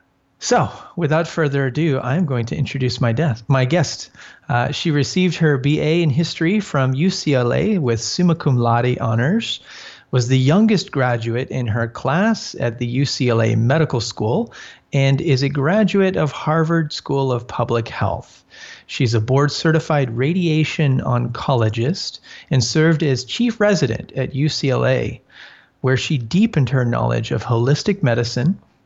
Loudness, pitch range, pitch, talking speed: -18 LUFS, 125-165 Hz, 140 Hz, 140 wpm